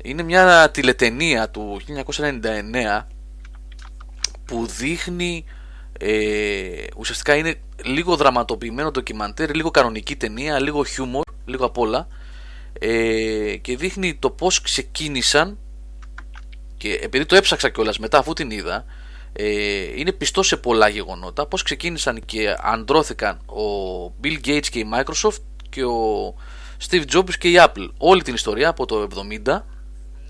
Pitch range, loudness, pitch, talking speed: 100-155 Hz, -20 LUFS, 125 Hz, 130 wpm